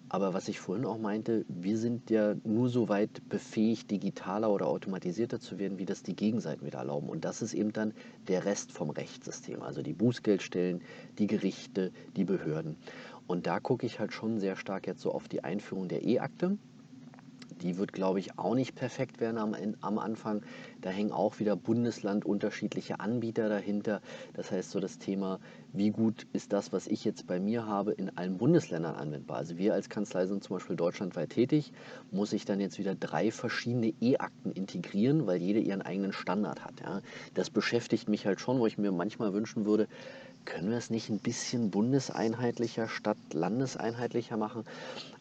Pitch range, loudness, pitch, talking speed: 100-115 Hz, -33 LUFS, 105 Hz, 185 wpm